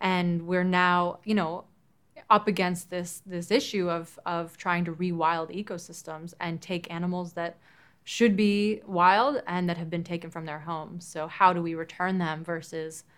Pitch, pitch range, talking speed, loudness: 175 Hz, 165-180 Hz, 175 wpm, -28 LUFS